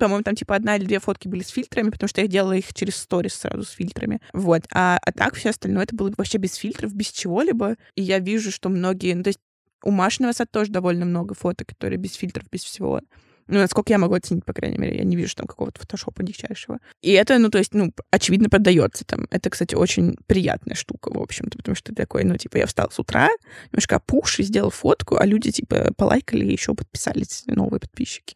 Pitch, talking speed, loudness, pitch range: 195 Hz, 225 wpm, -22 LUFS, 185-210 Hz